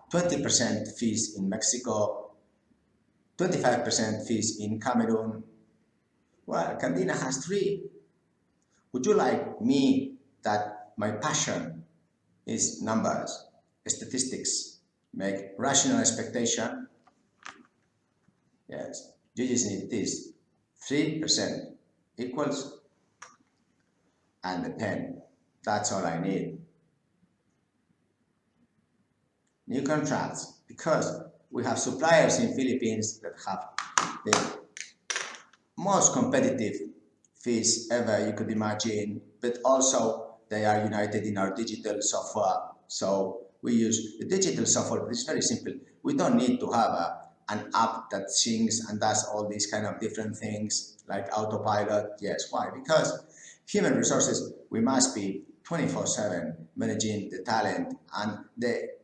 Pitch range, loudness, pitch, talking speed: 105-125 Hz, -28 LUFS, 110 Hz, 115 wpm